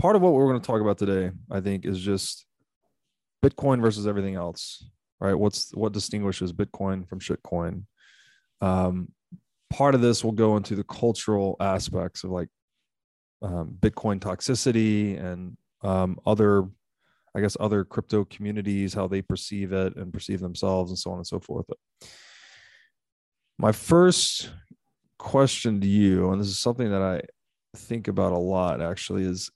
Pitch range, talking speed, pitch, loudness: 95-110 Hz, 160 wpm, 100 Hz, -25 LUFS